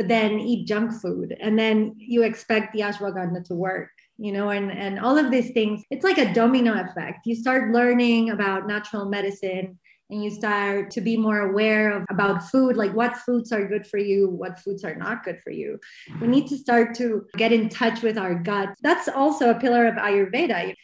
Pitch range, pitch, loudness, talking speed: 200-240 Hz, 215 Hz, -23 LUFS, 215 wpm